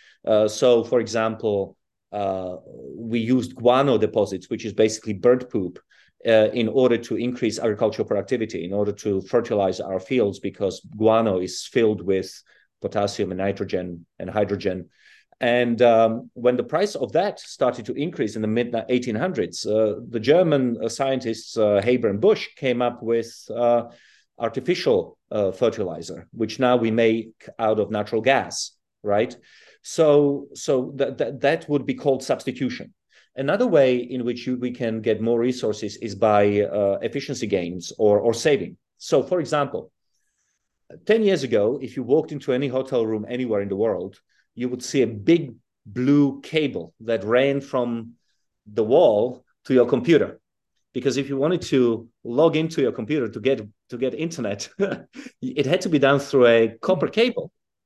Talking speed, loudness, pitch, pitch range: 165 wpm, -22 LUFS, 120 Hz, 110-135 Hz